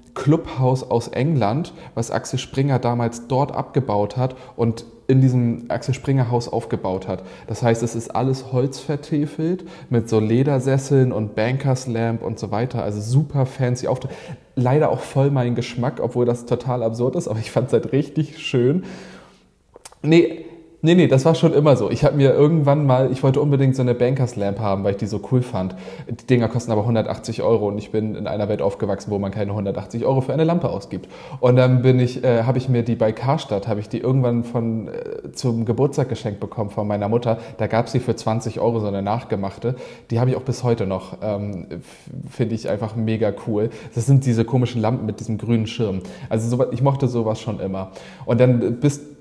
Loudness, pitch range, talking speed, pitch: -20 LUFS, 110-135 Hz, 205 wpm, 120 Hz